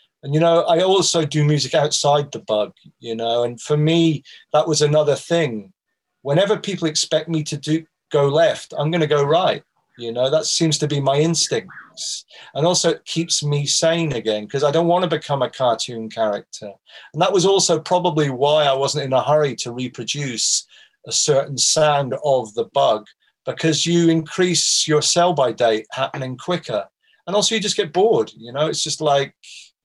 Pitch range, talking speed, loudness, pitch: 135-165 Hz, 190 wpm, -19 LUFS, 150 Hz